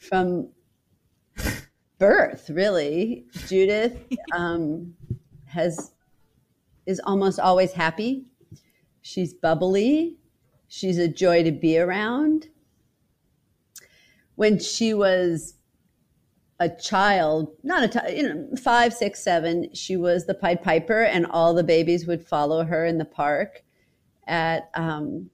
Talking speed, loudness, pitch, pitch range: 110 wpm, -23 LUFS, 175 Hz, 165-210 Hz